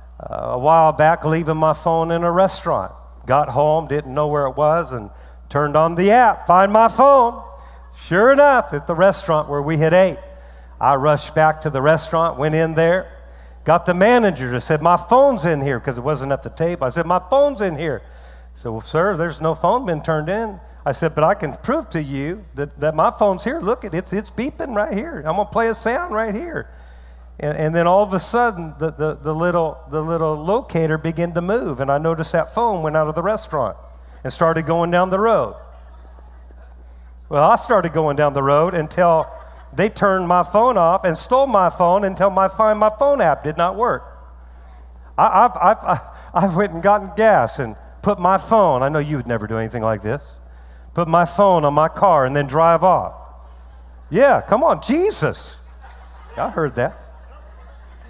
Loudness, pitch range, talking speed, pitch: -17 LUFS, 125-190 Hz, 205 wpm, 160 Hz